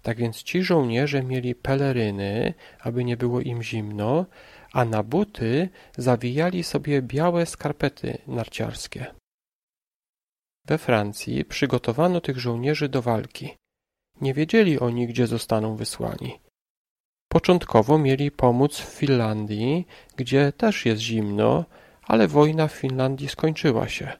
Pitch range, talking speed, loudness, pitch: 120-155 Hz, 115 wpm, -23 LUFS, 135 Hz